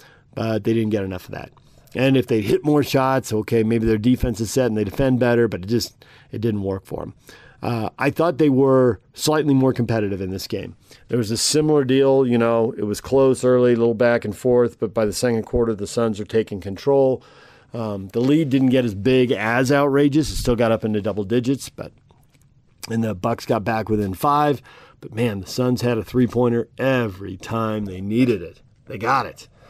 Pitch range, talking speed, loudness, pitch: 110-130 Hz, 215 wpm, -20 LUFS, 120 Hz